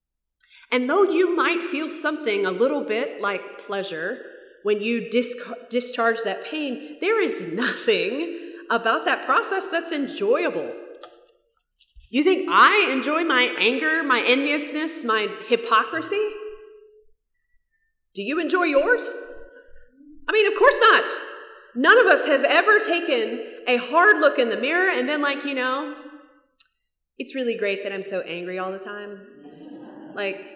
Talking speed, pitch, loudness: 140 wpm, 305 Hz, -21 LUFS